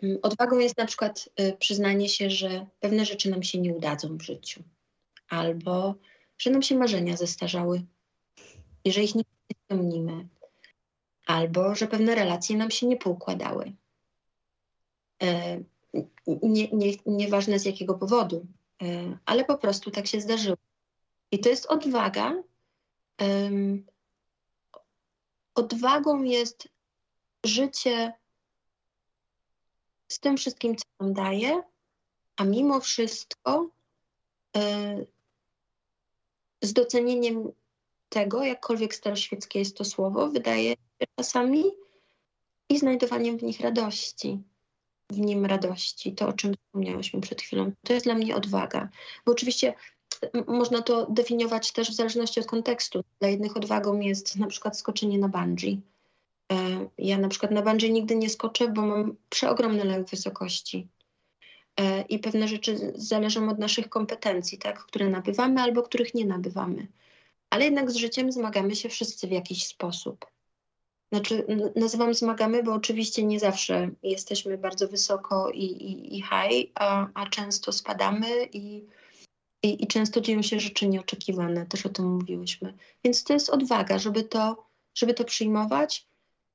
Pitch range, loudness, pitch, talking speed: 190-235 Hz, -27 LUFS, 210 Hz, 135 wpm